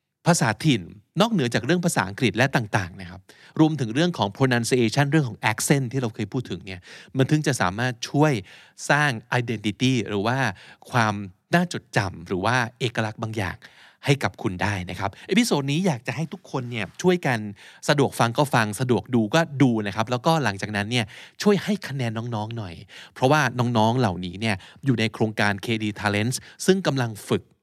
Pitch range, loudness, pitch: 105-145 Hz, -23 LUFS, 125 Hz